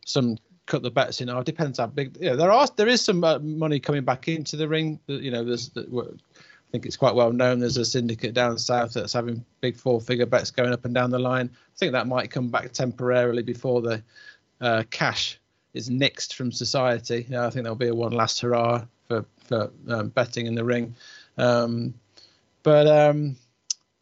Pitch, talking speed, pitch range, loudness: 125 Hz, 210 wpm, 120-140 Hz, -24 LUFS